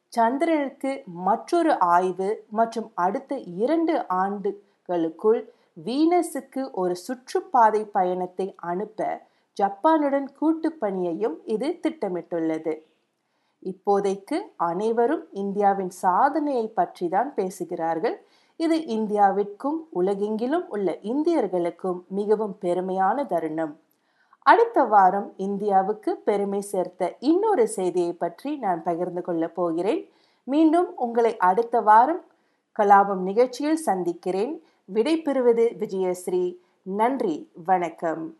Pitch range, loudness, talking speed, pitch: 180-275 Hz, -24 LUFS, 90 wpm, 205 Hz